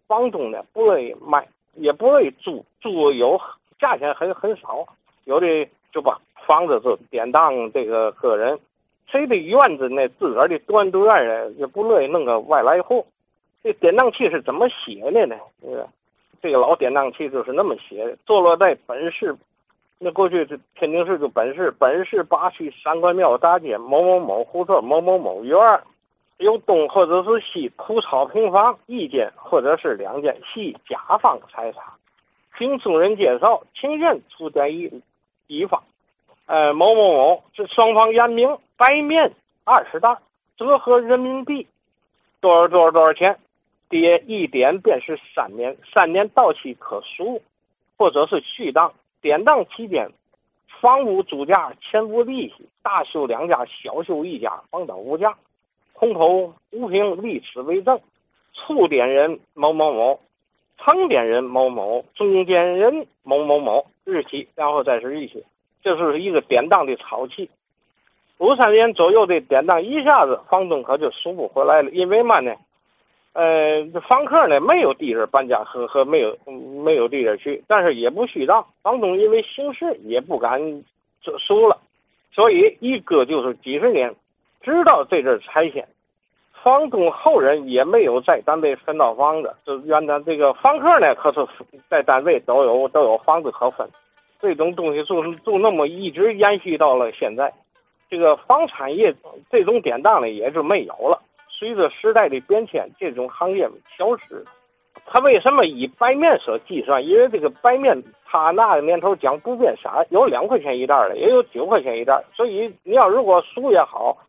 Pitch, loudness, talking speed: 225 Hz, -18 LUFS, 240 characters per minute